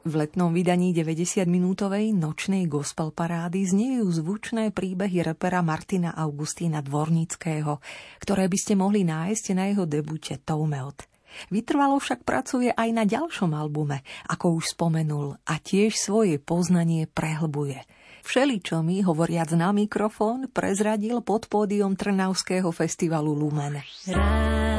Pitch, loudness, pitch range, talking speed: 175 Hz, -25 LUFS, 155-205 Hz, 120 wpm